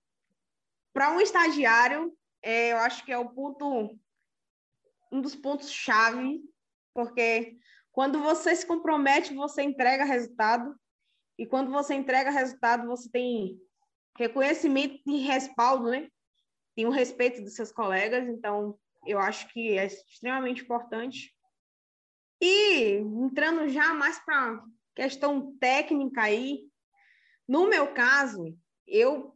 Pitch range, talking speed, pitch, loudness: 235-290 Hz, 115 wpm, 260 Hz, -27 LUFS